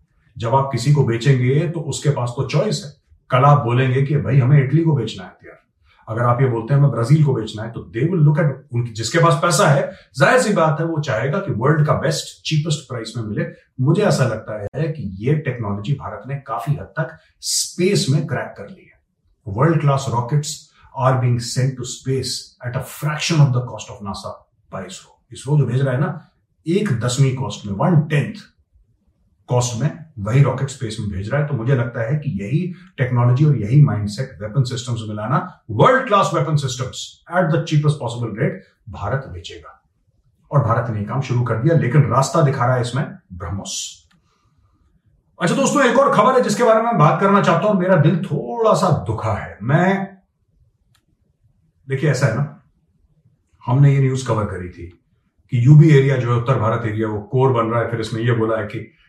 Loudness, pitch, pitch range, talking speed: -18 LUFS, 135 Hz, 115-155 Hz, 200 wpm